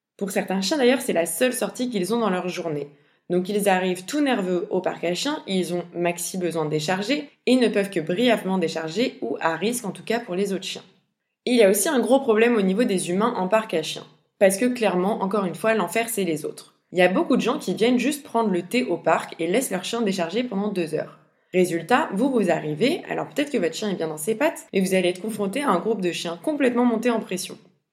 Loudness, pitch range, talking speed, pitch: -23 LUFS, 175-235 Hz, 260 wpm, 195 Hz